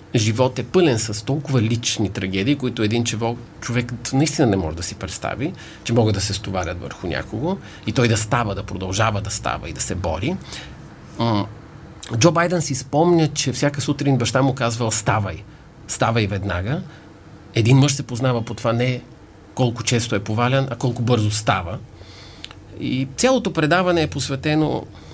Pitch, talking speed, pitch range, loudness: 120 Hz, 165 wpm, 105-135 Hz, -21 LUFS